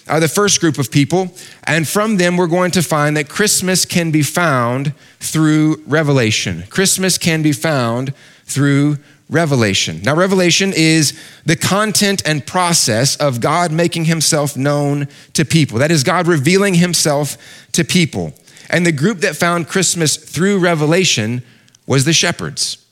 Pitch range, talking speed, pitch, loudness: 145-175 Hz, 150 wpm, 160 Hz, -14 LUFS